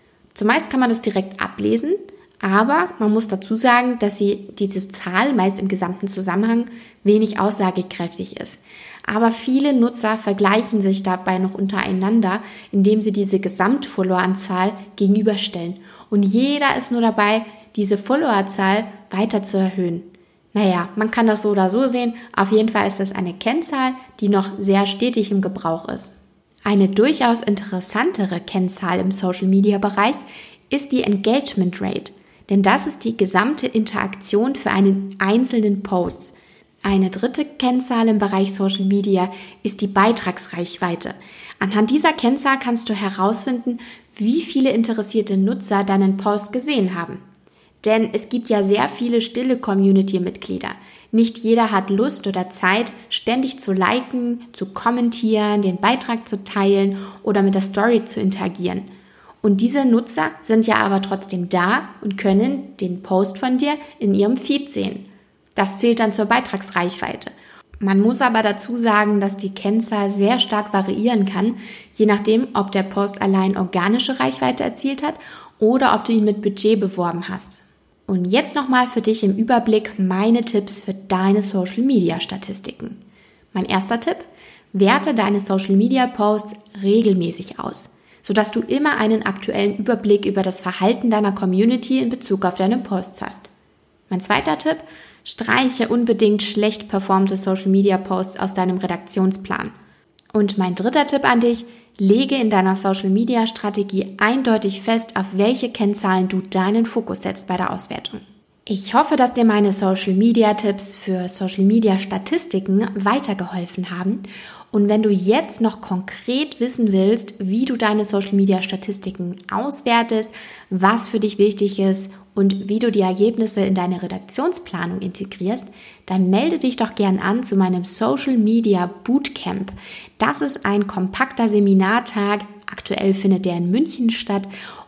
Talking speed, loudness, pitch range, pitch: 140 wpm, -19 LUFS, 195-230 Hz, 205 Hz